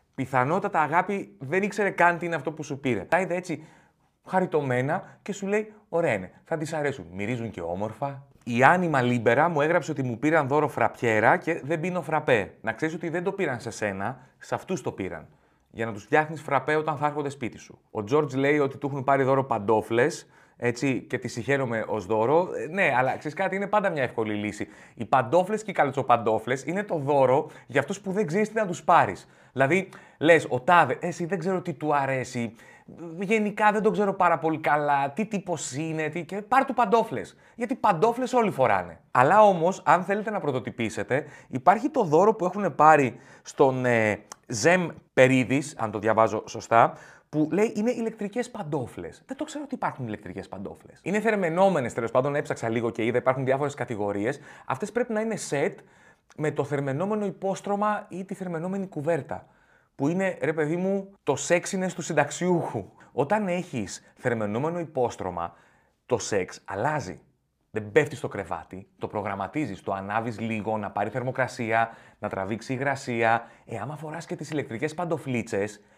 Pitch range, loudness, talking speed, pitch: 120-180 Hz, -26 LUFS, 180 wpm, 150 Hz